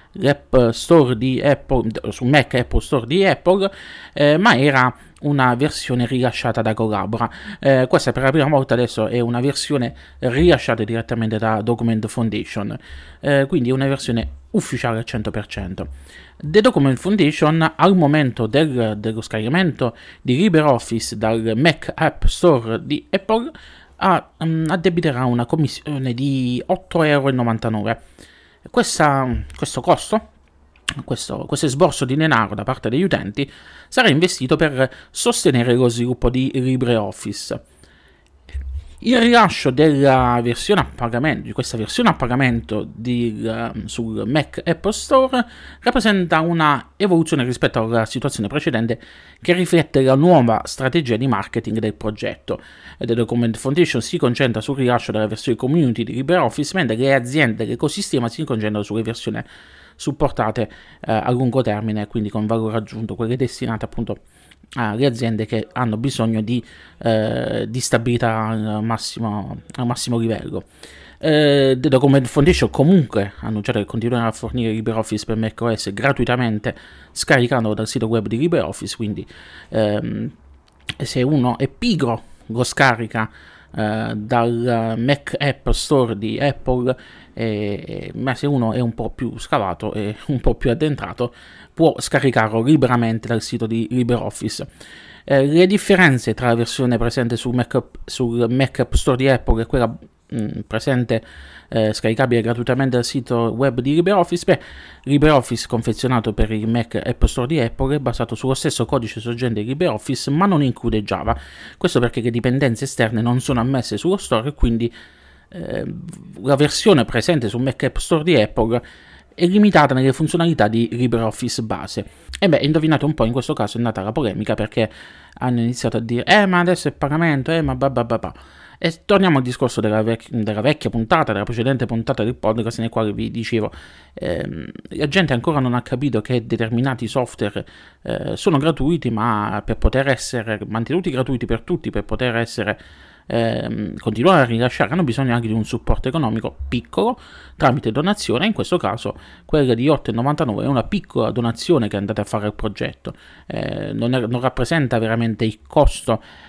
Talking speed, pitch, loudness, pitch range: 155 wpm, 120 Hz, -19 LUFS, 110-145 Hz